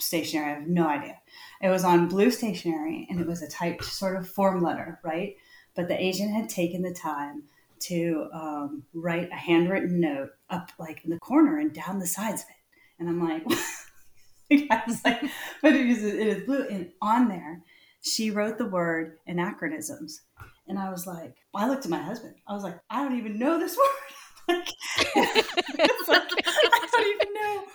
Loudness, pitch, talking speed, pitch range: -27 LUFS, 195 Hz, 190 wpm, 170-275 Hz